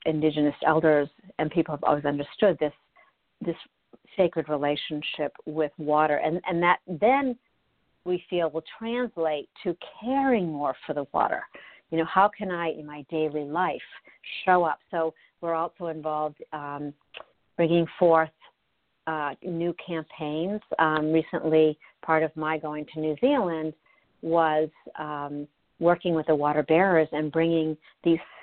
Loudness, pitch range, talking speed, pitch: -26 LUFS, 150-170 Hz, 140 wpm, 160 Hz